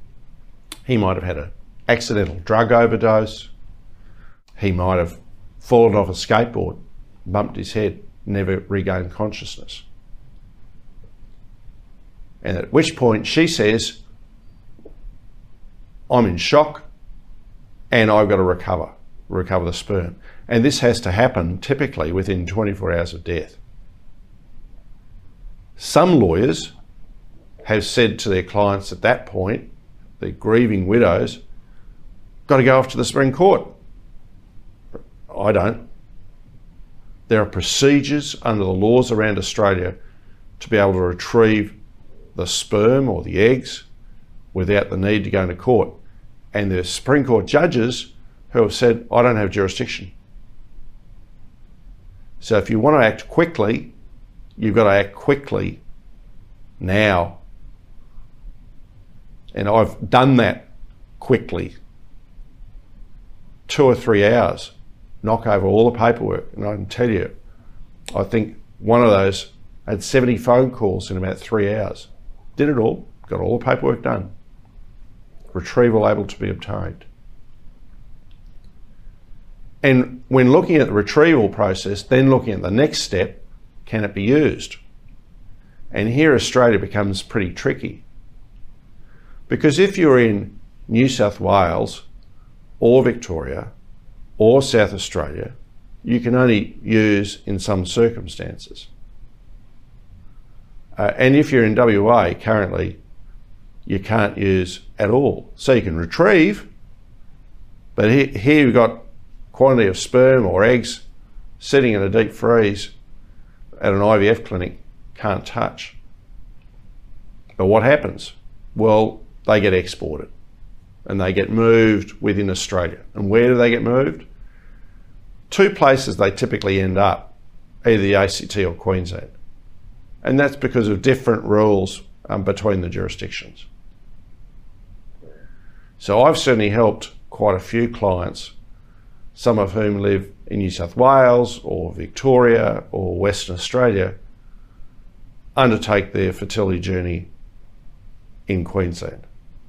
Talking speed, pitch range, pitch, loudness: 125 wpm, 95-120 Hz, 105 Hz, -18 LUFS